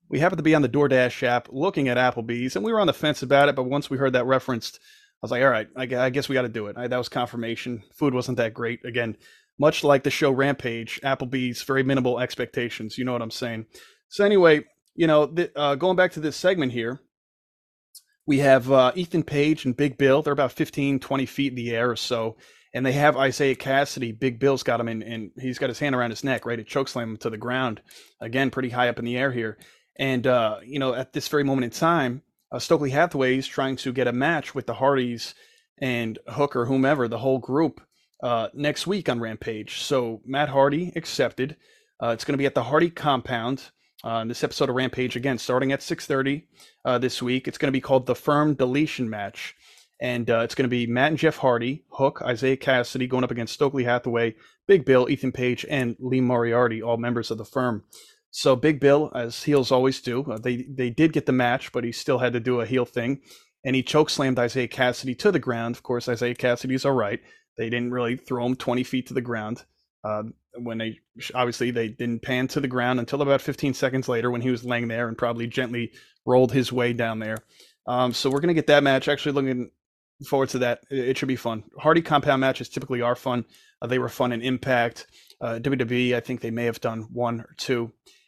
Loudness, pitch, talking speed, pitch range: -24 LUFS, 130 Hz, 230 wpm, 120-140 Hz